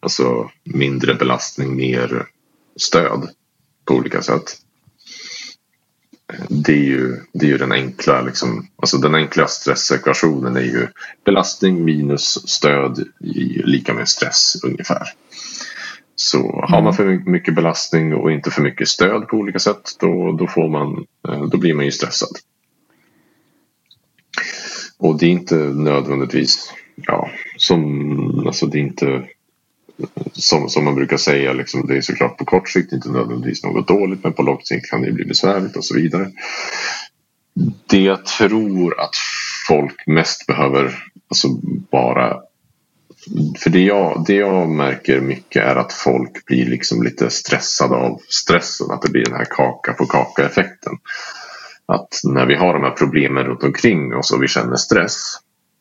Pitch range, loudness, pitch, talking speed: 65-80 Hz, -17 LUFS, 70 Hz, 150 wpm